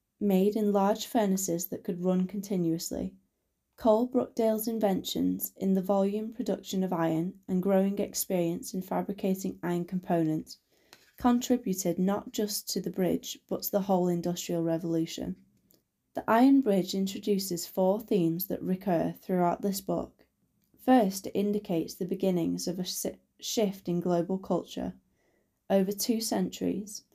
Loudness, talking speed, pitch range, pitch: -30 LUFS, 135 wpm, 175-205 Hz, 195 Hz